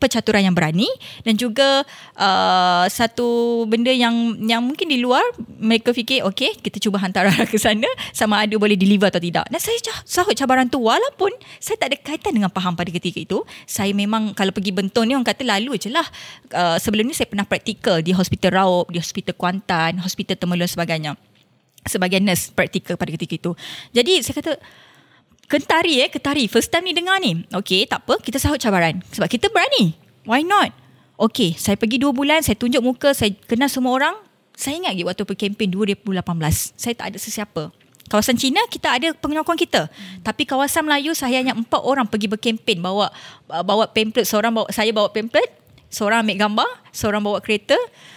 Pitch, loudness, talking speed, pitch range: 220 Hz, -19 LUFS, 185 wpm, 195-265 Hz